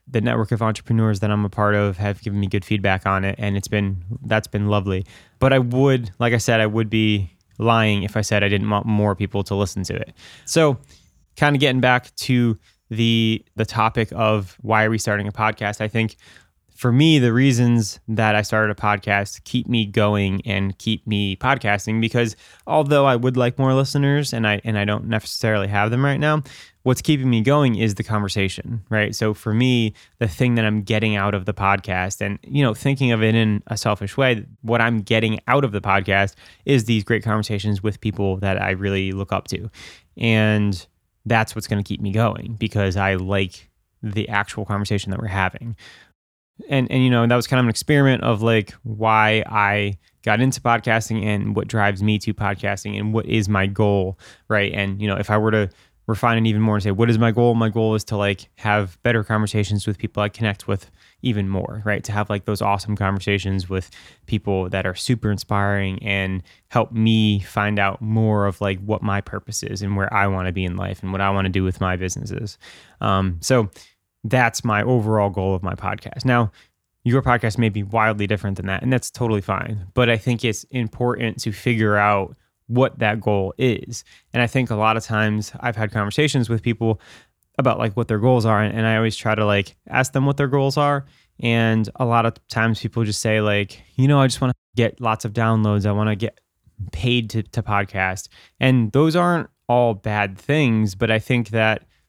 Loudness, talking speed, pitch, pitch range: -20 LUFS, 215 wpm, 110 Hz, 100-115 Hz